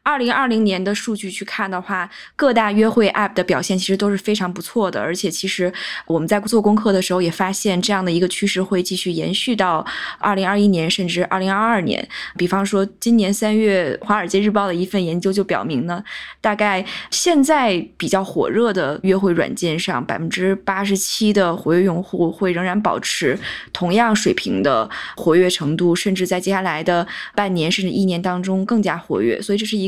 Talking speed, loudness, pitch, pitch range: 315 characters per minute, -18 LUFS, 195 Hz, 180-210 Hz